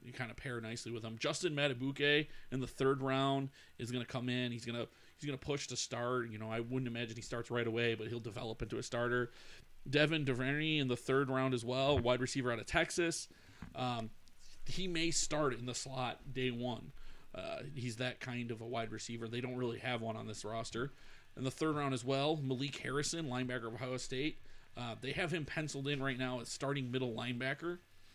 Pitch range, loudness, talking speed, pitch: 120-135 Hz, -38 LUFS, 220 wpm, 125 Hz